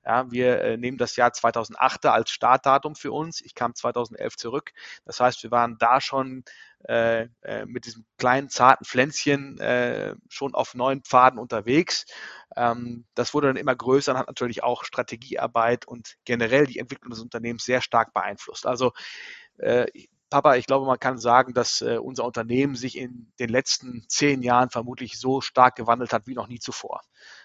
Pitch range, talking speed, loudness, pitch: 120-135 Hz, 175 wpm, -23 LUFS, 125 Hz